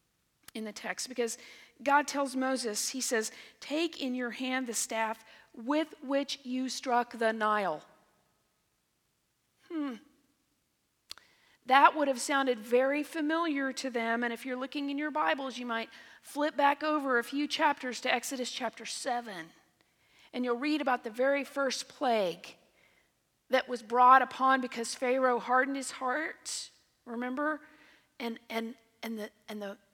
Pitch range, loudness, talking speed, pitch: 235-280 Hz, -31 LUFS, 145 wpm, 255 Hz